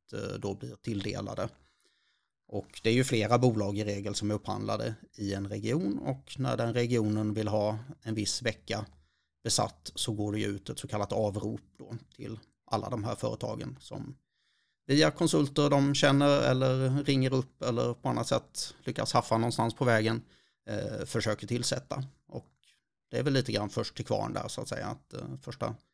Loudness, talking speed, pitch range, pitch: -31 LUFS, 180 wpm, 105-130 Hz, 115 Hz